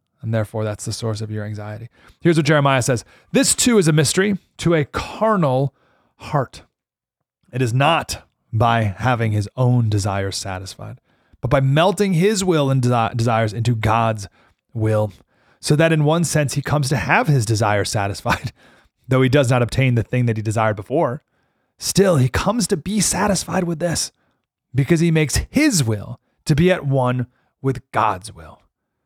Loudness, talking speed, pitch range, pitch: -19 LUFS, 170 wpm, 110-160 Hz, 125 Hz